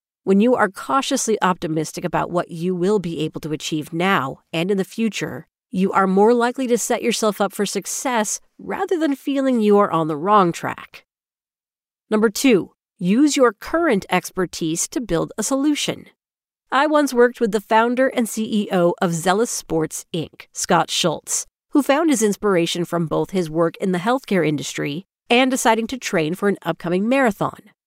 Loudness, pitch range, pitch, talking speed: -20 LUFS, 175-245 Hz, 205 Hz, 175 wpm